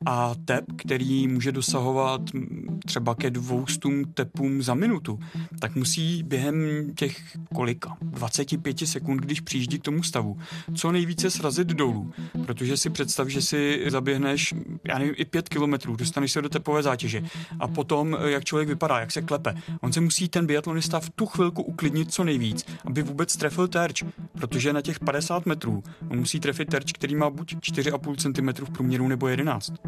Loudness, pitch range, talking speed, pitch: -26 LUFS, 135-165 Hz, 170 wpm, 145 Hz